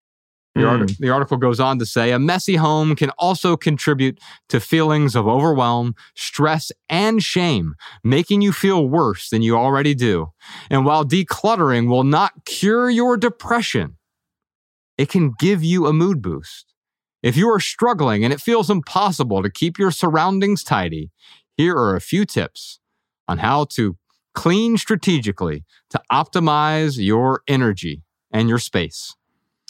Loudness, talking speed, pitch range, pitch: -18 LUFS, 150 wpm, 120-180 Hz, 150 Hz